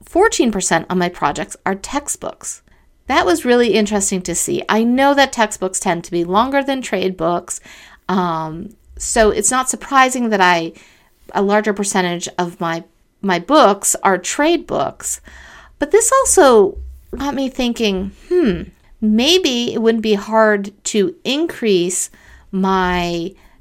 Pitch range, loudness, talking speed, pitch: 180-260 Hz, -16 LUFS, 140 wpm, 210 Hz